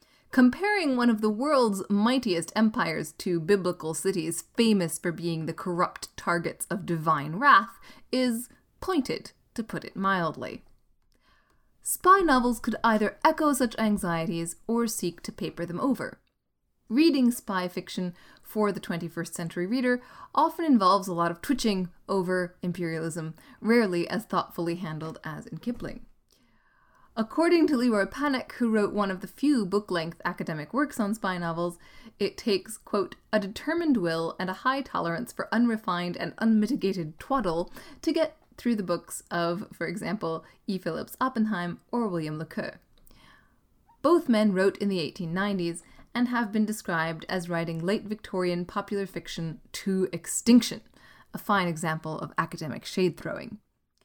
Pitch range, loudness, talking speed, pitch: 175-235 Hz, -27 LUFS, 145 wpm, 200 Hz